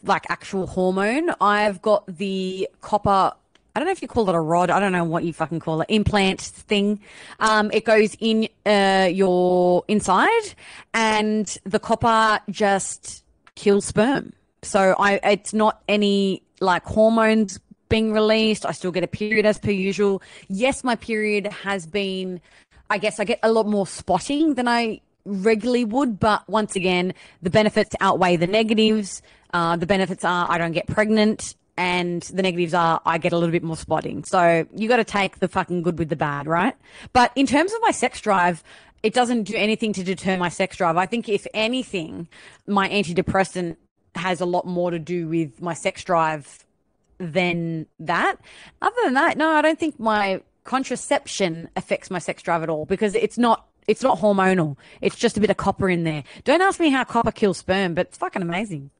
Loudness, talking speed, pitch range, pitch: -21 LUFS, 190 wpm, 180-220 Hz, 200 Hz